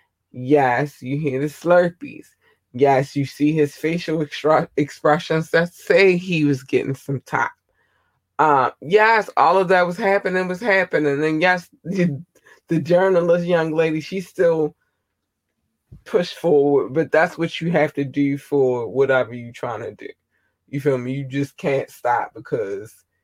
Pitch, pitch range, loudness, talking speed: 155 Hz, 140-180 Hz, -19 LUFS, 150 wpm